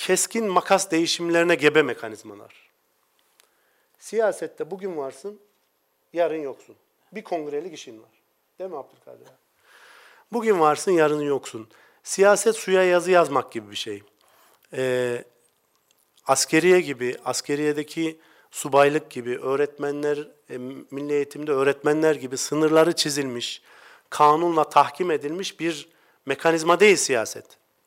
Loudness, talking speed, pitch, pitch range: -22 LUFS, 105 wpm, 155 Hz, 140-185 Hz